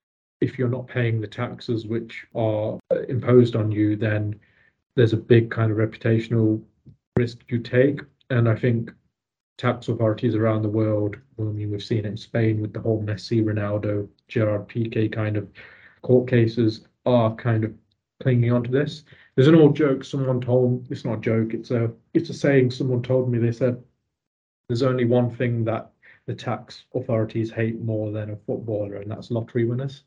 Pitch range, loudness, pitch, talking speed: 110-125 Hz, -23 LUFS, 115 Hz, 180 wpm